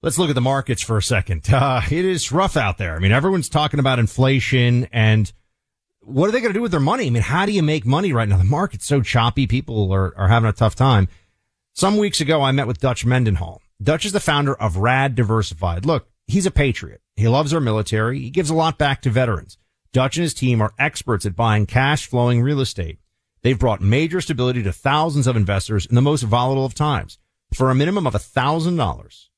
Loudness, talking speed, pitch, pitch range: -19 LUFS, 230 wpm, 125 Hz, 105-145 Hz